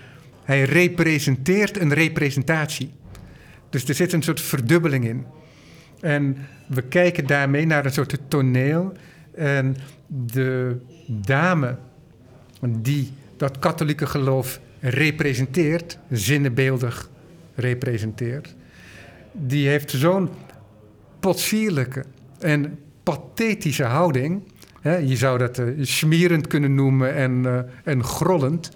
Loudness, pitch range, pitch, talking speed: -22 LUFS, 130-160 Hz, 140 Hz, 90 wpm